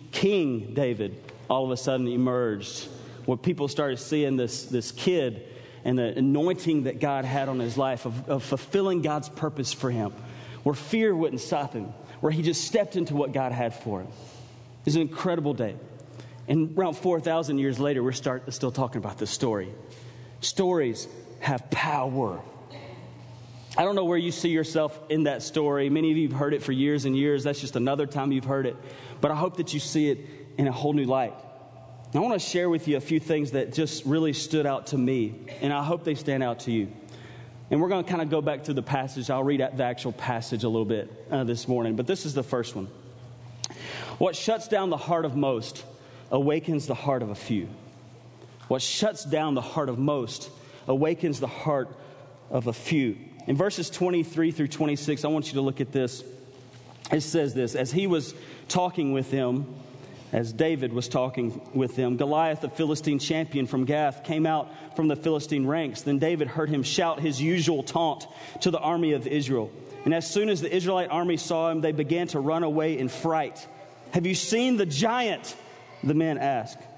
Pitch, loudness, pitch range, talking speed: 140 Hz, -27 LUFS, 125-155 Hz, 205 wpm